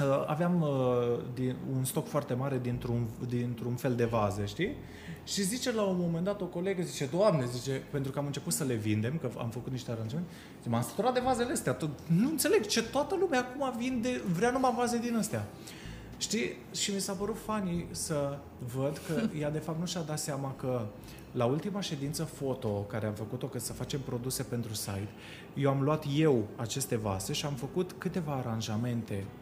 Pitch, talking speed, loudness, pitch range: 140 Hz, 195 wpm, -33 LUFS, 120-180 Hz